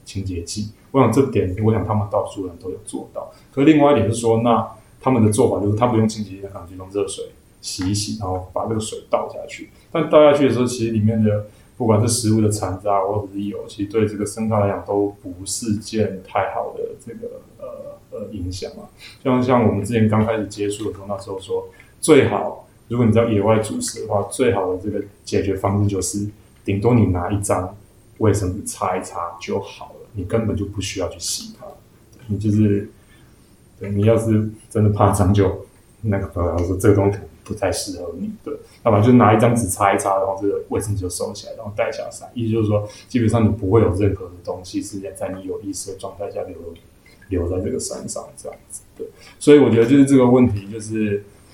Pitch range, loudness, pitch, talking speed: 100-115 Hz, -19 LUFS, 105 Hz, 325 characters per minute